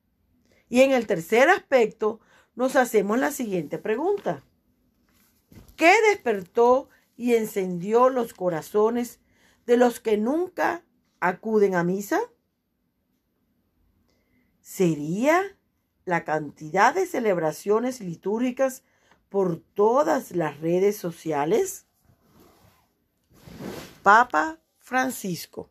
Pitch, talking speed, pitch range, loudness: 220 Hz, 85 wpm, 185-260 Hz, -23 LUFS